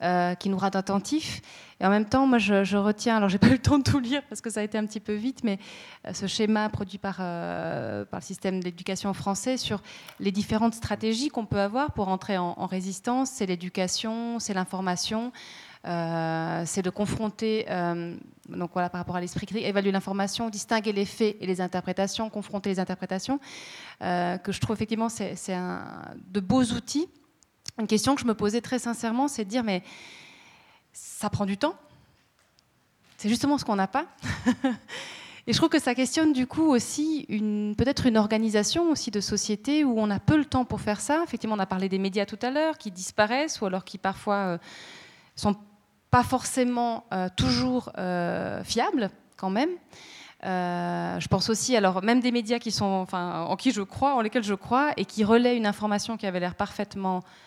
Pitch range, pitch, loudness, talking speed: 190-240 Hz, 210 Hz, -27 LUFS, 205 wpm